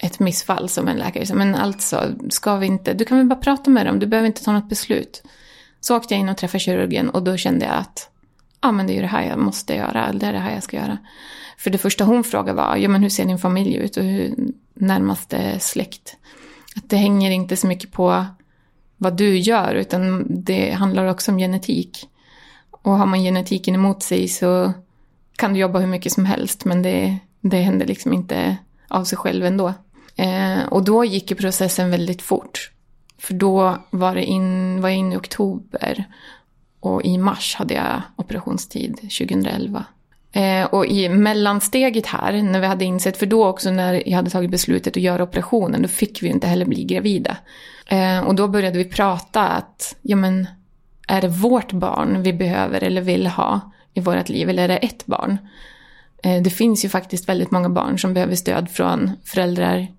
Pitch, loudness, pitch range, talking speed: 190 Hz, -19 LUFS, 185-205 Hz, 200 wpm